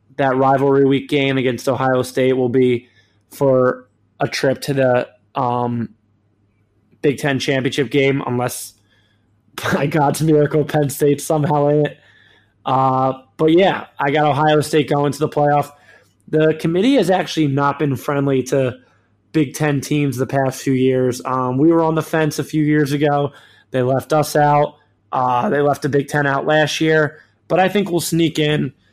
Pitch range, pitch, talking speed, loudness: 130-150 Hz, 140 Hz, 175 wpm, -17 LUFS